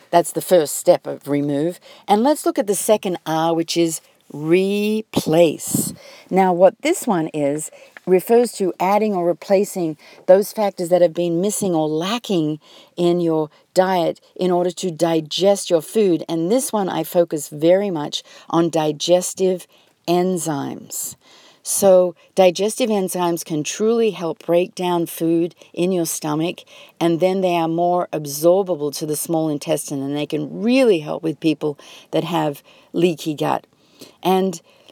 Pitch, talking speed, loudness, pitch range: 175 Hz, 150 wpm, -19 LUFS, 160-190 Hz